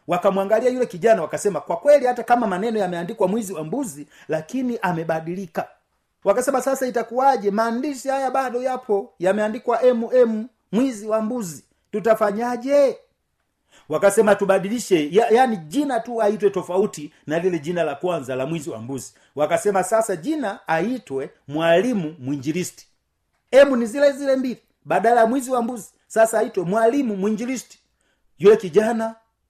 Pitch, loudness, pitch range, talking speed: 220 Hz, -21 LUFS, 180-245 Hz, 115 wpm